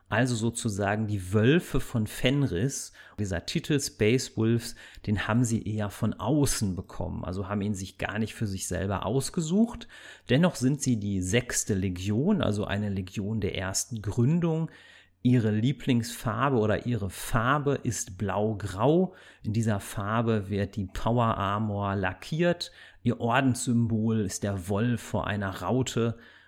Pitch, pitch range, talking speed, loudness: 110 Hz, 100-125 Hz, 140 wpm, -28 LUFS